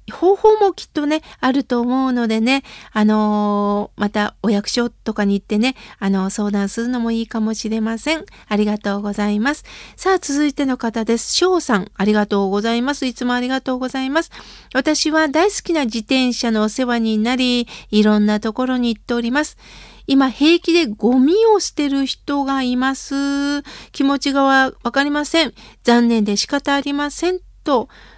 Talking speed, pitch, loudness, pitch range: 335 characters per minute, 250 Hz, -18 LUFS, 220-285 Hz